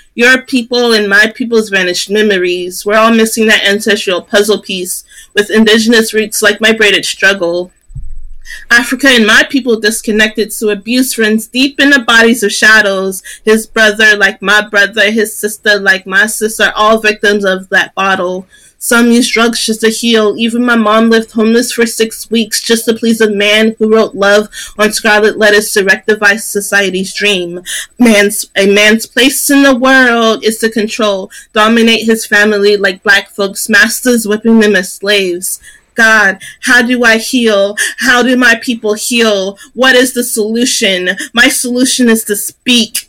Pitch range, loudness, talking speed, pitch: 205-230 Hz, -9 LUFS, 170 wpm, 215 Hz